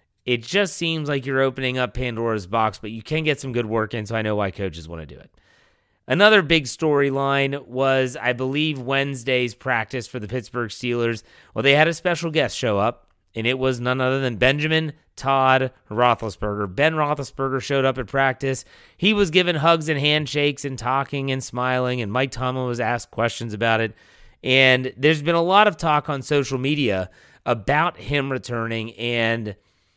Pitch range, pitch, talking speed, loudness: 115-145 Hz, 130 Hz, 185 wpm, -21 LUFS